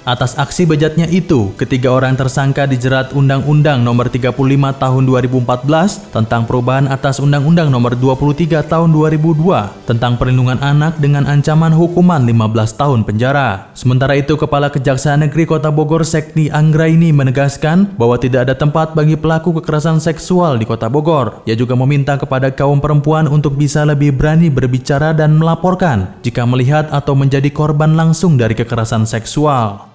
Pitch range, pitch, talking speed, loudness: 130-155 Hz, 145 Hz, 145 wpm, -12 LUFS